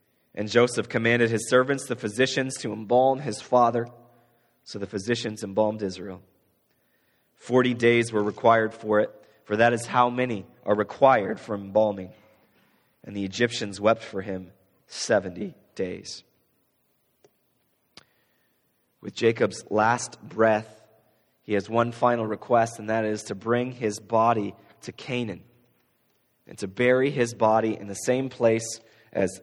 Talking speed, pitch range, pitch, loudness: 135 wpm, 105-120 Hz, 115 Hz, -25 LUFS